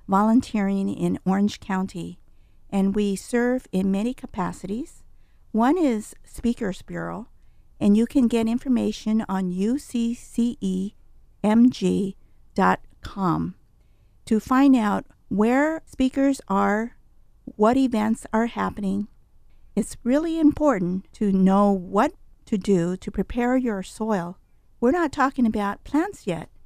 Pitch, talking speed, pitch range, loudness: 220 Hz, 110 wpm, 195-250 Hz, -23 LUFS